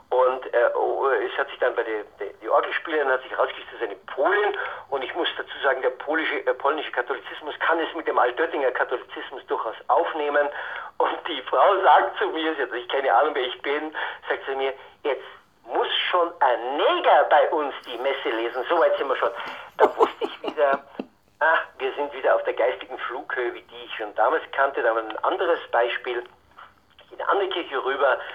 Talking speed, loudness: 200 wpm, -24 LUFS